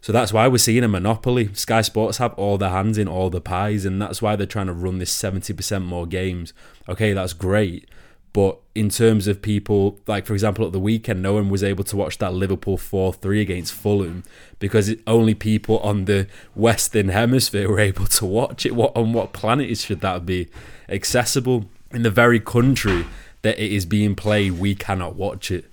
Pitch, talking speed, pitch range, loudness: 105 Hz, 210 wpm, 95-110 Hz, -20 LUFS